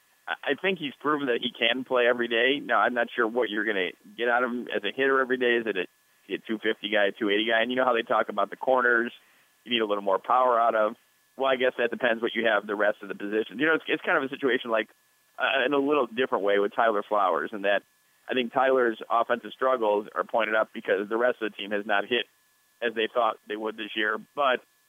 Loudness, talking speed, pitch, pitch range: -26 LUFS, 265 wpm, 115 Hz, 105-125 Hz